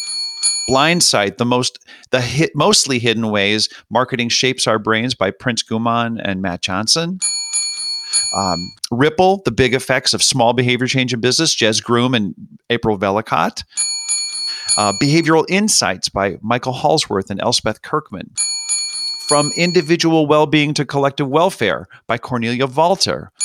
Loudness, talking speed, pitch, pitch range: -16 LUFS, 135 wpm, 125 Hz, 110-150 Hz